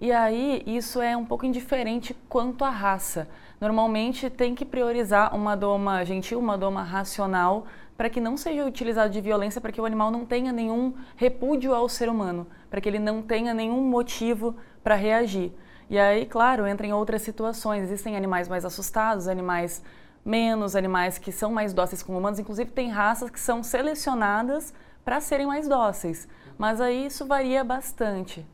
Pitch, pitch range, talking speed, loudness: 225 Hz, 200-245 Hz, 170 wpm, -26 LUFS